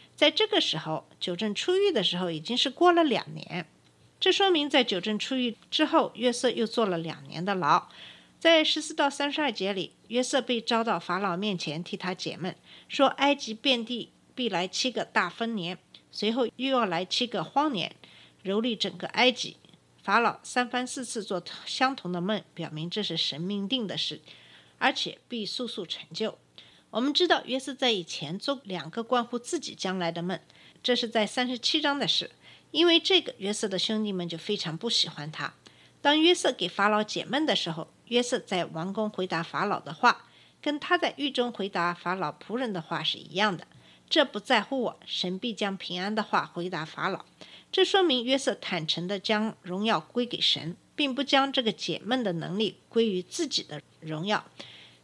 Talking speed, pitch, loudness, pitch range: 270 characters per minute, 215 Hz, -28 LUFS, 180-260 Hz